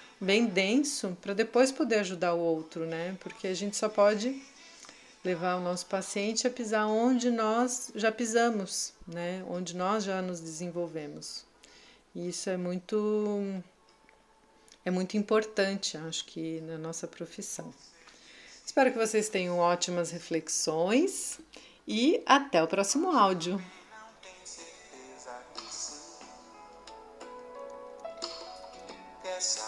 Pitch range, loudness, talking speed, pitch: 170-220 Hz, -30 LUFS, 105 wpm, 190 Hz